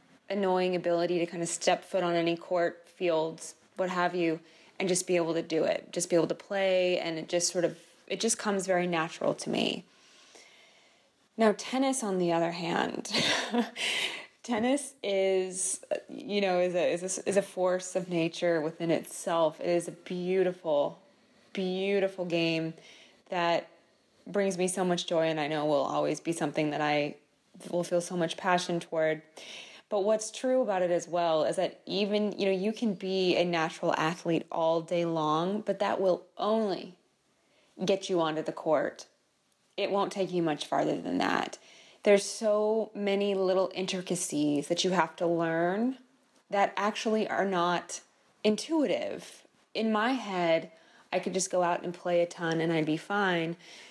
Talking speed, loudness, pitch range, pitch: 175 wpm, -30 LUFS, 170-195 Hz, 180 Hz